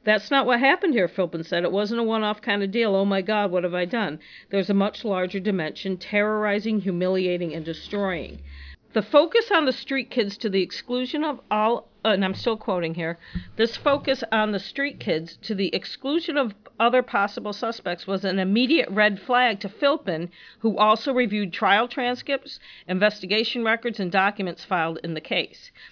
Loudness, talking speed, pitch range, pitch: -24 LUFS, 190 wpm, 190-240 Hz, 210 Hz